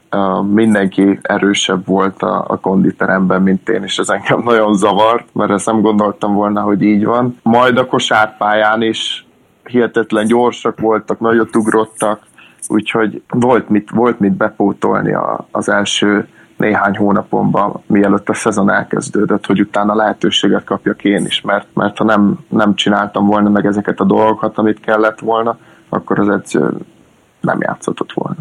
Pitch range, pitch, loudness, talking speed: 100-110 Hz, 105 Hz, -13 LUFS, 150 wpm